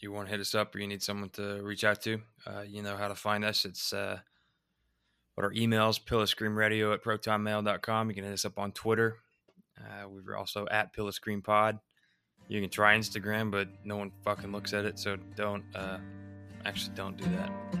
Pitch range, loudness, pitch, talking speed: 100-110 Hz, -32 LUFS, 105 Hz, 210 wpm